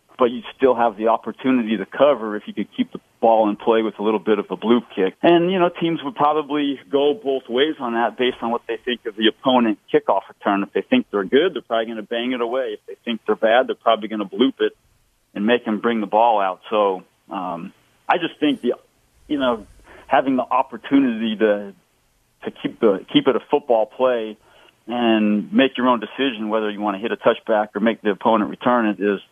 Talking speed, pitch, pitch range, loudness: 235 wpm, 115 Hz, 110-135 Hz, -20 LUFS